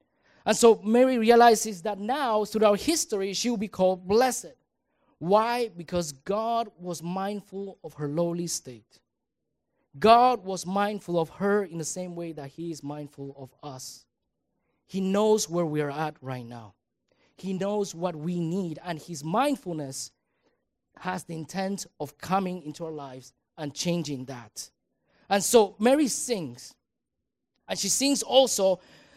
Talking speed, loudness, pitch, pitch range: 150 wpm, -26 LUFS, 185 Hz, 155-215 Hz